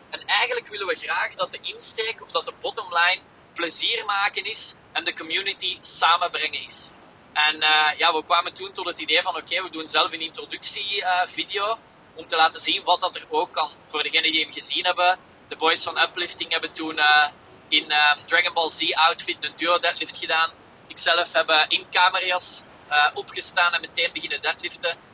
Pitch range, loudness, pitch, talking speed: 160-190 Hz, -21 LUFS, 170 Hz, 195 wpm